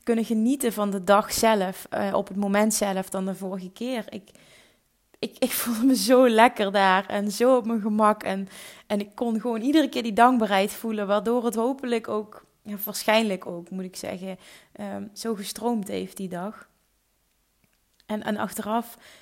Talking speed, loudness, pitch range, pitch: 180 wpm, -24 LUFS, 200-235 Hz, 215 Hz